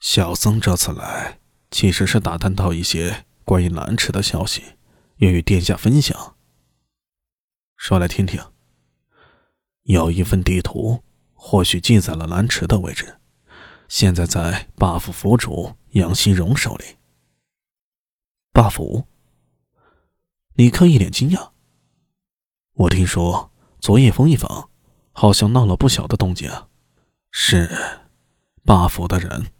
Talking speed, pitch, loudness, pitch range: 175 characters per minute, 90 Hz, -18 LUFS, 85-105 Hz